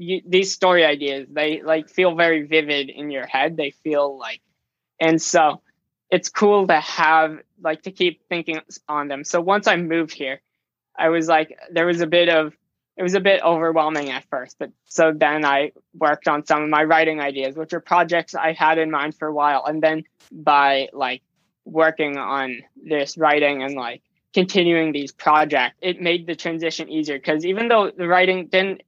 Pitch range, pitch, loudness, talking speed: 150-175 Hz, 160 Hz, -20 LUFS, 190 wpm